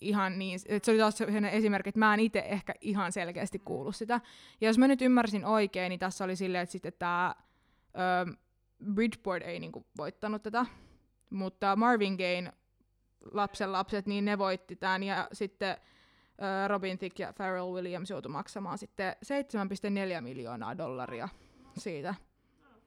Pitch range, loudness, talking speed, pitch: 180-210 Hz, -32 LUFS, 150 wpm, 195 Hz